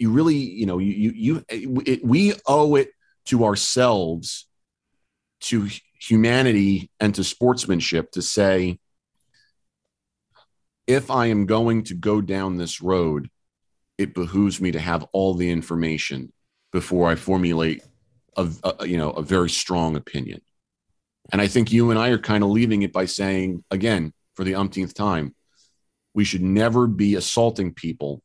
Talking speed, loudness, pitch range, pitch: 155 wpm, -22 LUFS, 90-115 Hz, 100 Hz